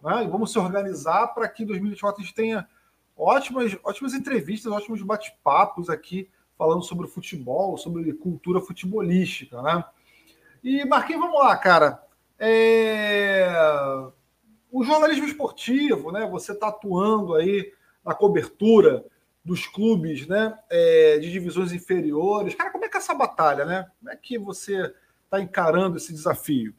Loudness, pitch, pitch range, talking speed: -23 LUFS, 205 Hz, 180-230 Hz, 145 wpm